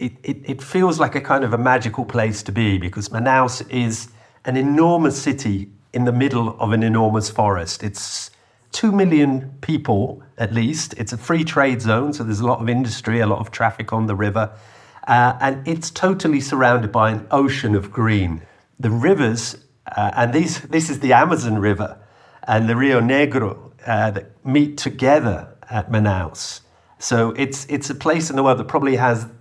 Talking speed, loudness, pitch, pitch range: 190 wpm, -19 LUFS, 120 Hz, 110-140 Hz